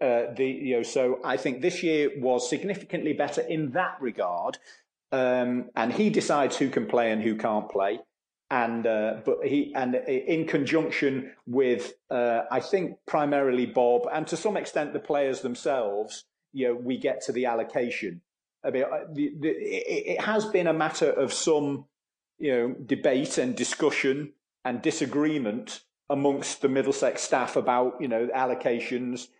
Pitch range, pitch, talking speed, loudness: 125-160 Hz, 140 Hz, 155 wpm, -27 LUFS